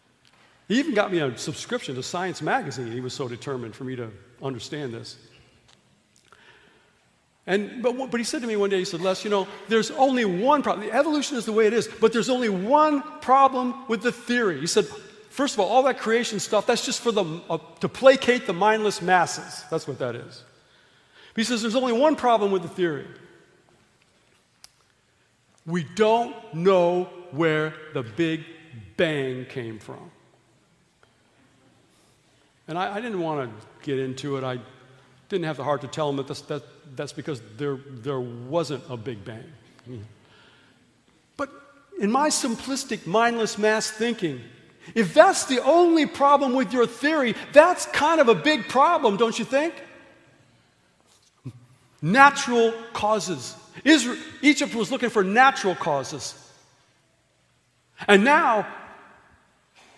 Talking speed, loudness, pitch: 155 wpm, -23 LUFS, 195 Hz